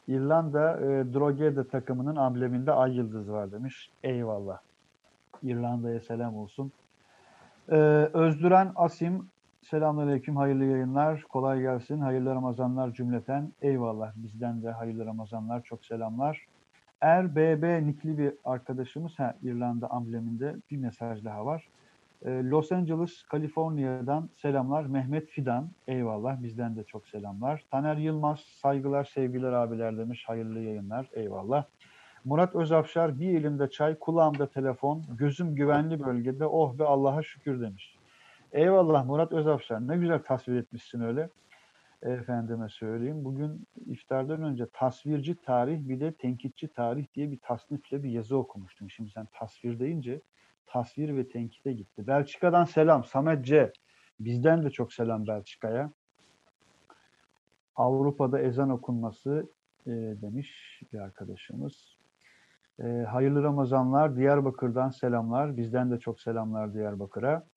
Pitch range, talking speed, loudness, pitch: 120-150 Hz, 120 wpm, -29 LUFS, 130 Hz